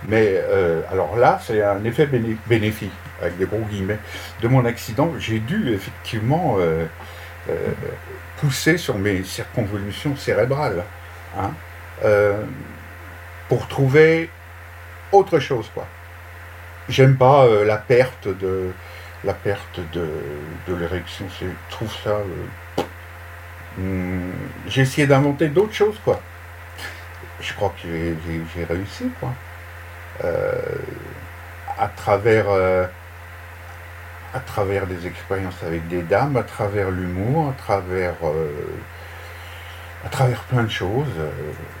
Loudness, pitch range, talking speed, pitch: -21 LUFS, 85-110 Hz, 120 wpm, 90 Hz